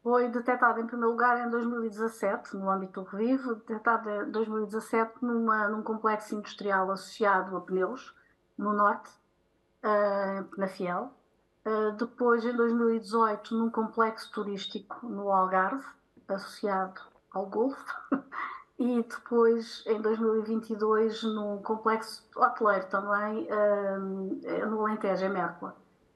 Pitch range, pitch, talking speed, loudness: 200-230 Hz, 220 Hz, 115 wpm, -30 LUFS